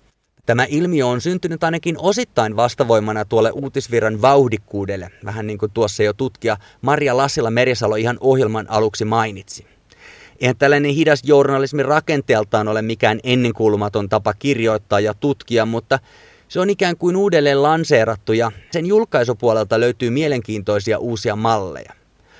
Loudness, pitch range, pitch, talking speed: -17 LUFS, 110-140 Hz, 120 Hz, 130 wpm